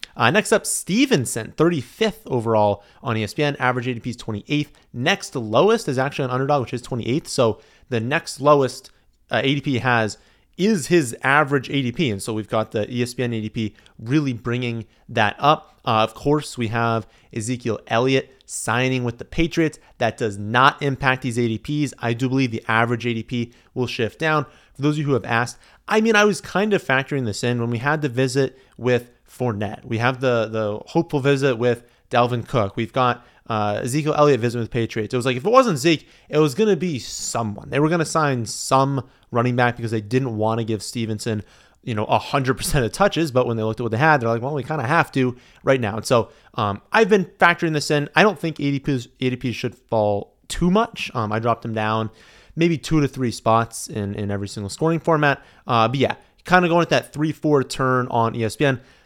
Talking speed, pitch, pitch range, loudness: 210 wpm, 125 Hz, 115-150 Hz, -21 LUFS